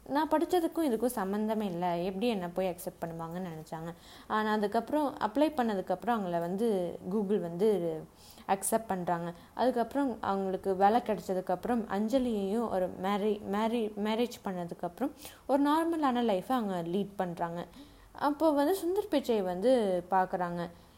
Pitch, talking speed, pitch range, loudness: 210 Hz, 125 wpm, 185-245 Hz, -31 LUFS